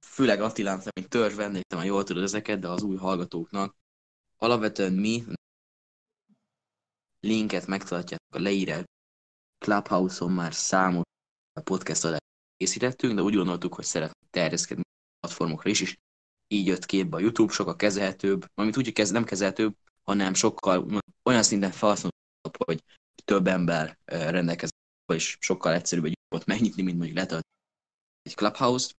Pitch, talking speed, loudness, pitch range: 95 Hz, 140 wpm, -27 LUFS, 85-105 Hz